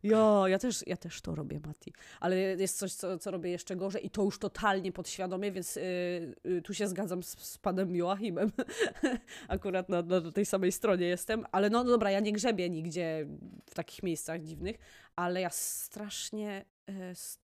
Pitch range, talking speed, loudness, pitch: 175-205 Hz, 190 wpm, -33 LUFS, 190 Hz